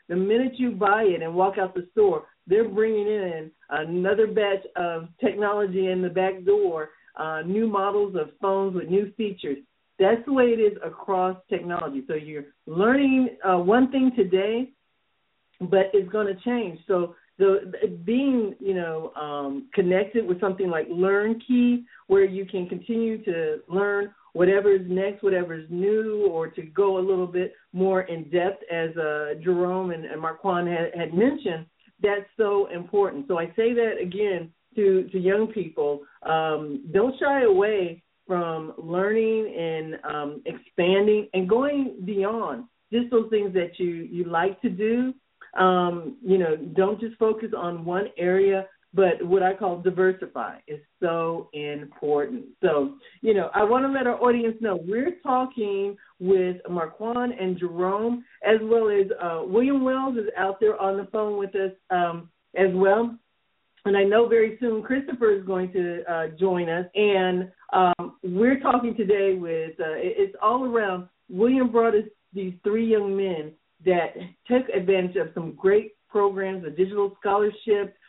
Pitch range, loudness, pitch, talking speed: 180-220 Hz, -24 LUFS, 195 Hz, 160 wpm